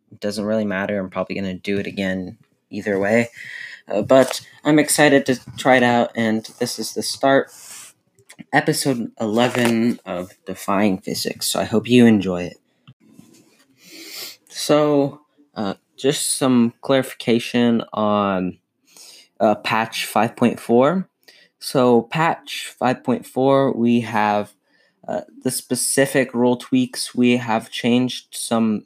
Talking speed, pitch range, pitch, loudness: 125 wpm, 105-130 Hz, 120 Hz, -19 LUFS